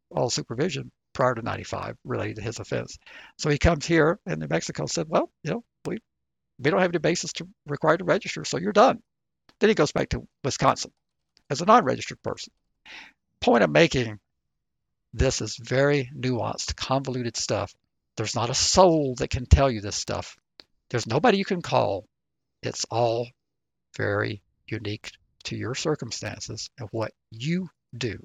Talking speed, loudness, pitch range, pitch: 170 wpm, -25 LUFS, 110-145 Hz, 120 Hz